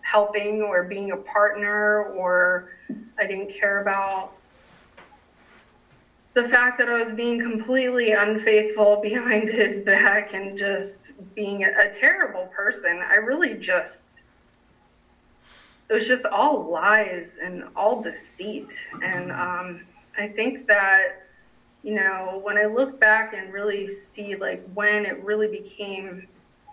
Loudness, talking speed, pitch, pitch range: -22 LUFS, 130 wpm, 210 Hz, 195-220 Hz